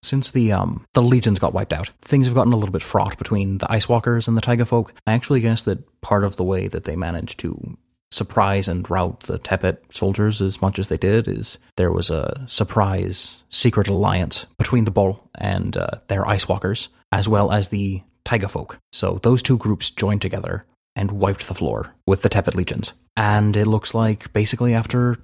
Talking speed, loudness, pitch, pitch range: 200 wpm, -21 LUFS, 105 Hz, 95-115 Hz